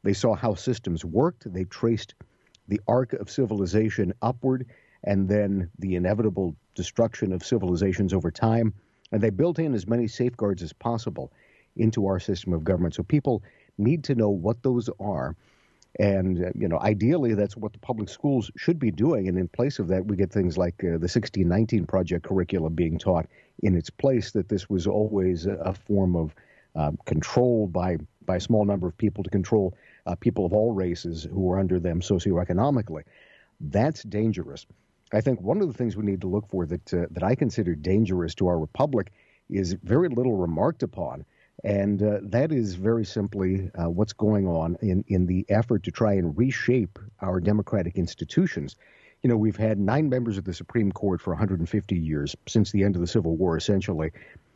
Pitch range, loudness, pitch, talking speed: 90-115 Hz, -26 LUFS, 100 Hz, 185 wpm